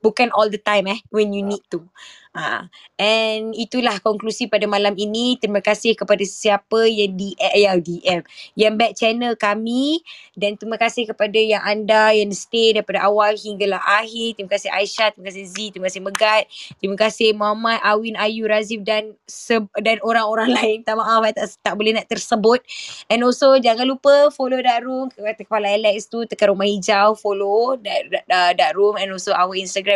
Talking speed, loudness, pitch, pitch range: 175 wpm, -18 LUFS, 215 Hz, 205-225 Hz